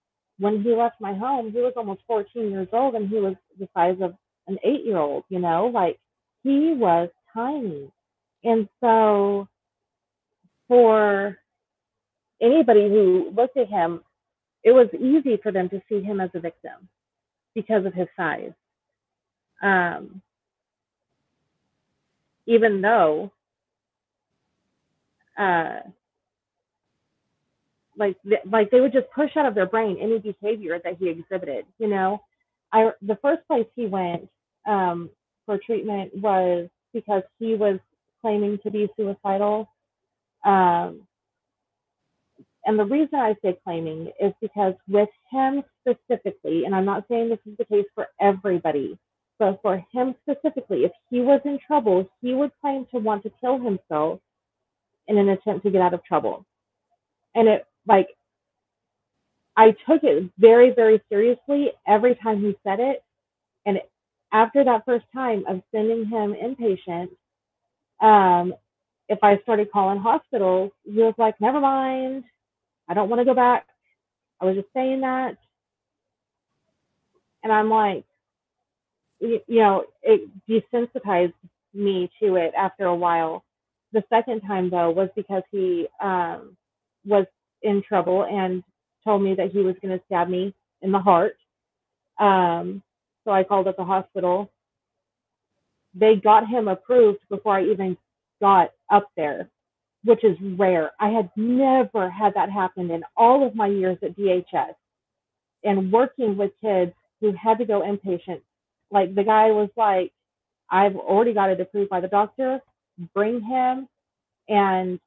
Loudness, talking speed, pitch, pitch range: -22 LUFS, 145 wpm, 205 Hz, 190-230 Hz